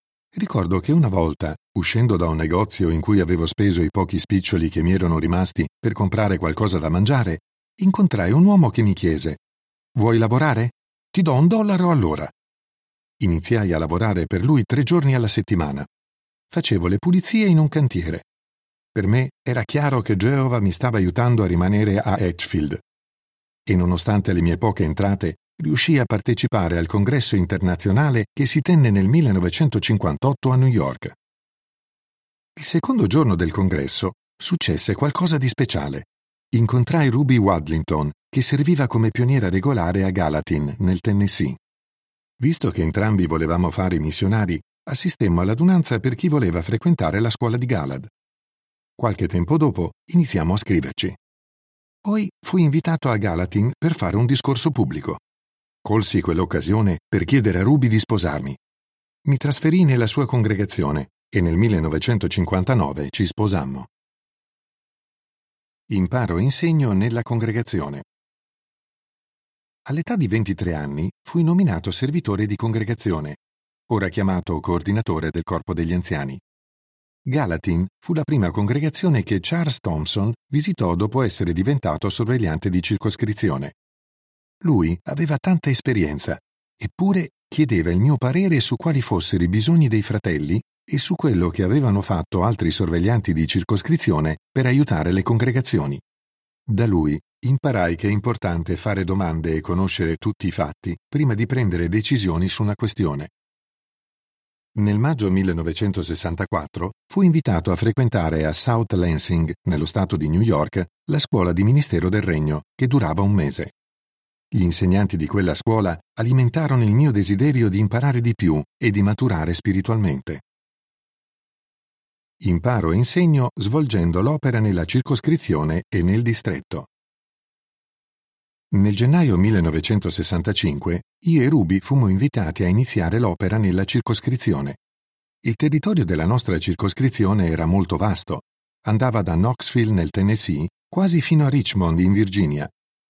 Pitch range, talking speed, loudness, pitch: 90-130 Hz, 135 wpm, -20 LUFS, 105 Hz